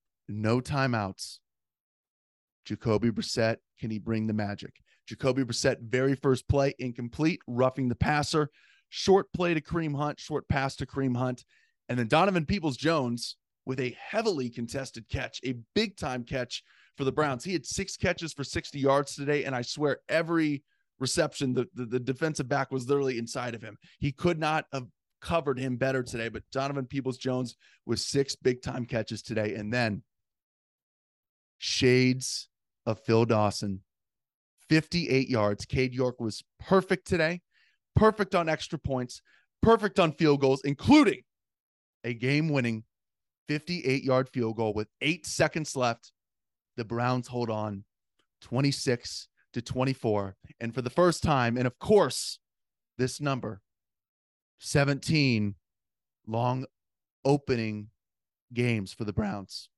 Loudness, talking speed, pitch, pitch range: -29 LUFS, 145 wpm, 130 Hz, 115-145 Hz